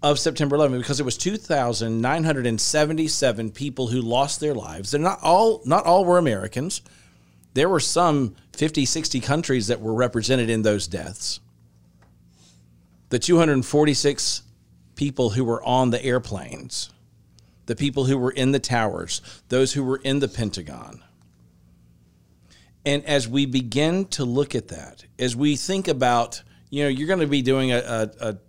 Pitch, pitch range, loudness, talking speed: 125 Hz, 105-145 Hz, -22 LUFS, 155 wpm